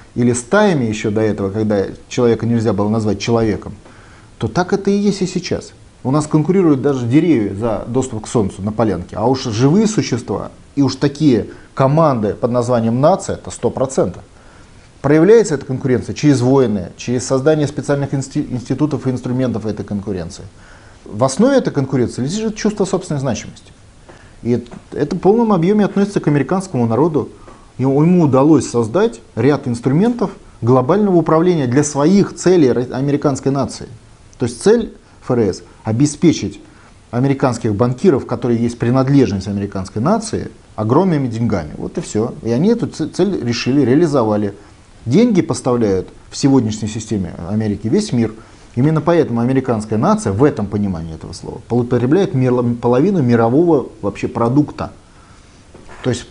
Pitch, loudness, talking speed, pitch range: 125 Hz, -16 LUFS, 140 wpm, 110-150 Hz